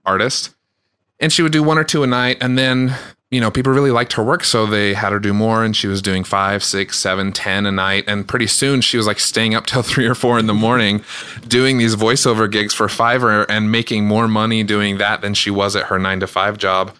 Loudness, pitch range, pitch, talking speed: -15 LUFS, 100-125 Hz, 110 Hz, 250 wpm